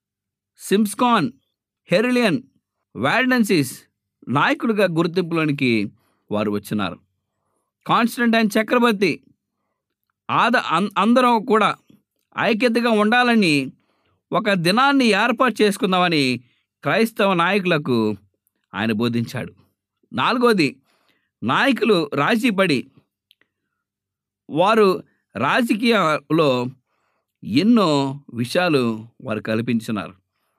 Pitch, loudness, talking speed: 180 Hz, -19 LUFS, 60 wpm